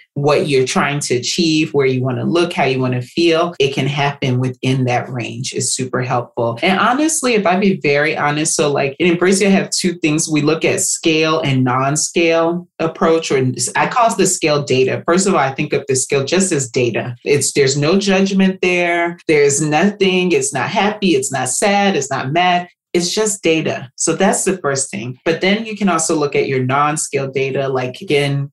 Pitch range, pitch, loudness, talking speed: 135-180 Hz, 155 Hz, -15 LUFS, 210 wpm